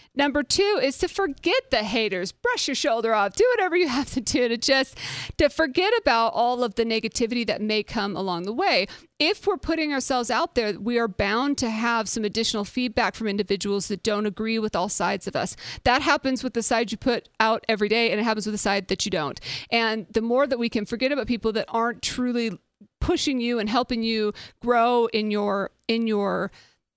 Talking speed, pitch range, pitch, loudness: 215 wpm, 215-265 Hz, 230 Hz, -24 LUFS